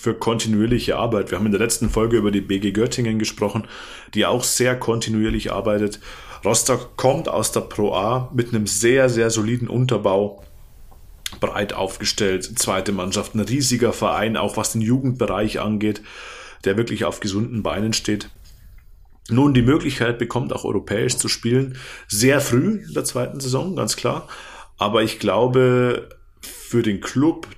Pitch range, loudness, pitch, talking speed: 105-120 Hz, -20 LUFS, 110 Hz, 155 wpm